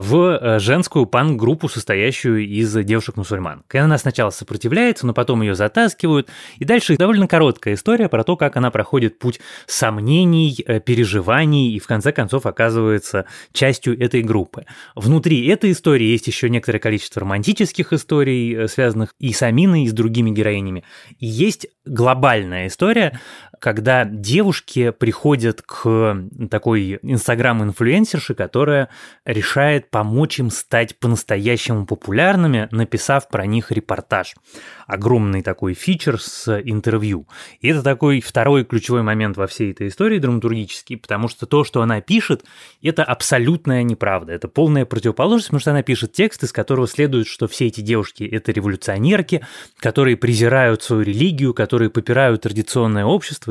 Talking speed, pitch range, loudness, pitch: 135 wpm, 110-145 Hz, -17 LUFS, 120 Hz